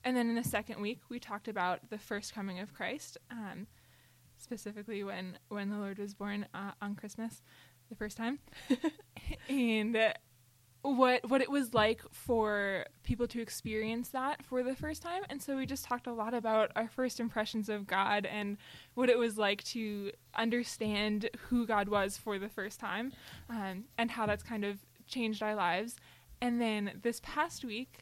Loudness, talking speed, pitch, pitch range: -36 LUFS, 180 wpm, 220 Hz, 205-245 Hz